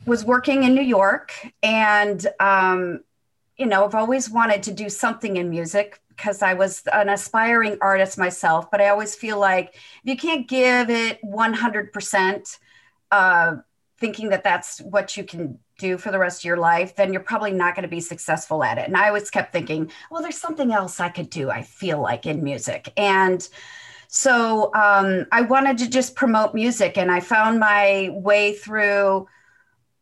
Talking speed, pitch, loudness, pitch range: 180 wpm, 205 Hz, -20 LUFS, 190-230 Hz